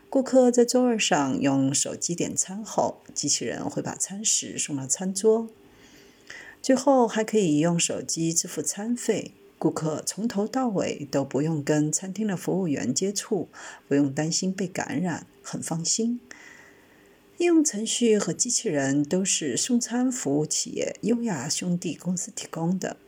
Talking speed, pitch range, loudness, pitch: 230 characters per minute, 155-230 Hz, -25 LUFS, 190 Hz